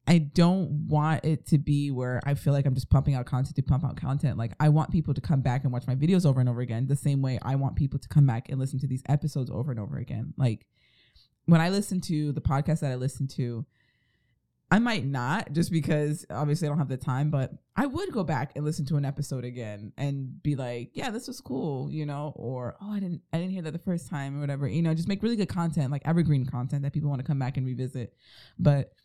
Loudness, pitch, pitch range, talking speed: -28 LUFS, 140 Hz, 130-155 Hz, 260 wpm